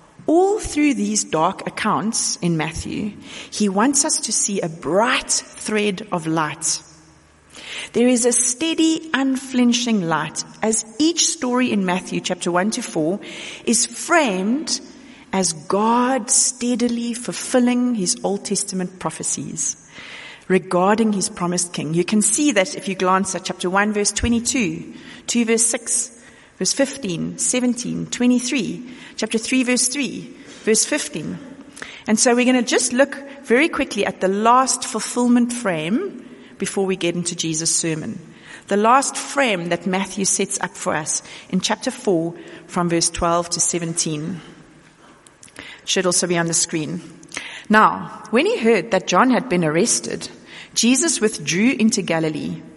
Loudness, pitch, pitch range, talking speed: -19 LUFS, 215 Hz, 185-250 Hz, 145 wpm